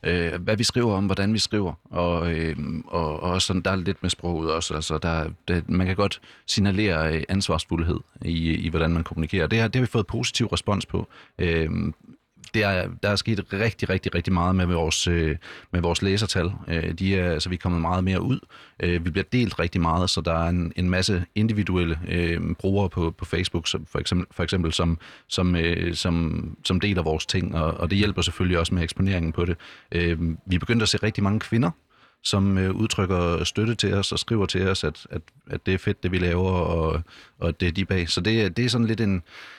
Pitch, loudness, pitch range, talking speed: 90 Hz, -24 LUFS, 85-100 Hz, 225 wpm